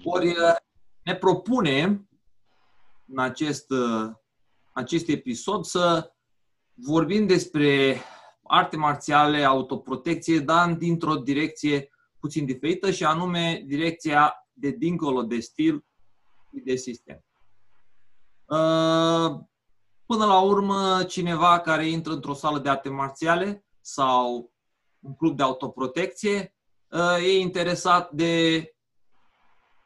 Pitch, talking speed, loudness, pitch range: 160 Hz, 95 wpm, -24 LUFS, 135-175 Hz